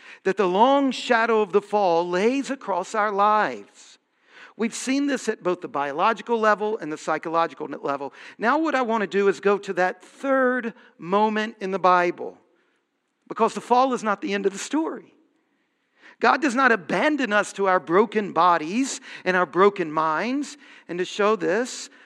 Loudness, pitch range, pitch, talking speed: -22 LUFS, 185-255 Hz, 210 Hz, 175 wpm